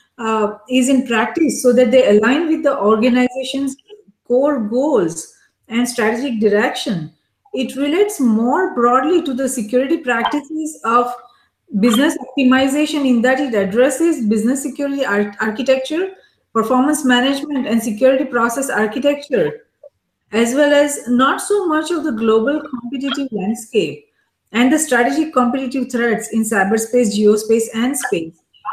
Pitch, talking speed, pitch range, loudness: 255 Hz, 130 wpm, 230-285 Hz, -16 LUFS